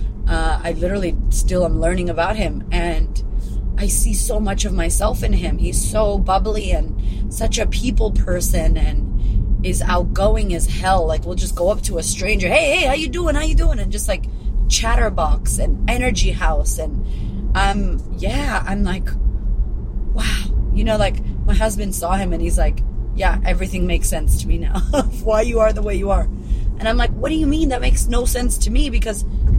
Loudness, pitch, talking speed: -20 LUFS, 185 Hz, 195 wpm